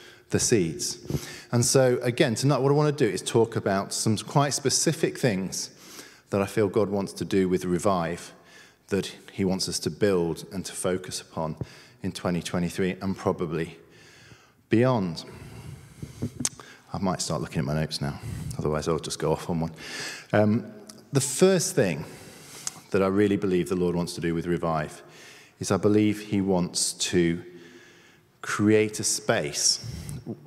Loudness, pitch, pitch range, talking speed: -26 LUFS, 100 Hz, 90-125 Hz, 160 wpm